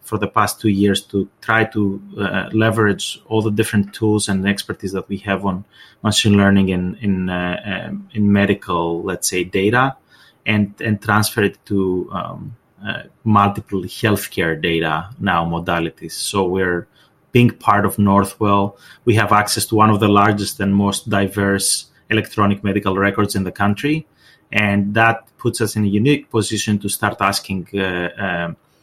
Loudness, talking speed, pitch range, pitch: -18 LUFS, 165 wpm, 95-110 Hz, 100 Hz